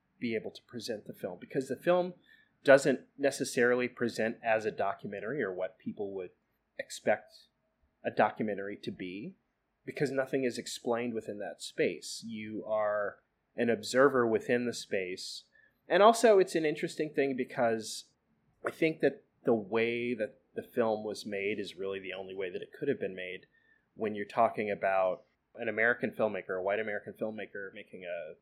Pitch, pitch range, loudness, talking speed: 120 Hz, 110-140 Hz, -32 LUFS, 165 wpm